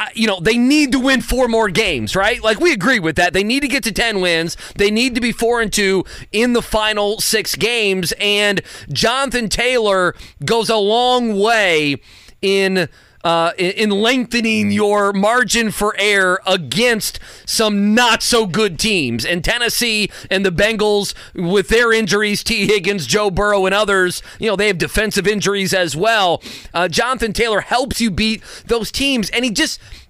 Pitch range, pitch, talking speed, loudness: 190-230 Hz, 210 Hz, 175 wpm, -15 LUFS